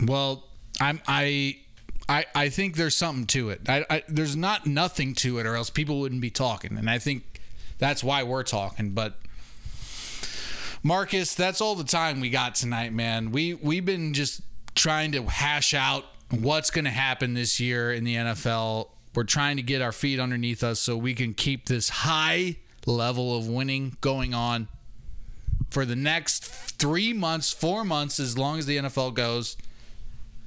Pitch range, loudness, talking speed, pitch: 120-150 Hz, -26 LUFS, 175 wpm, 135 Hz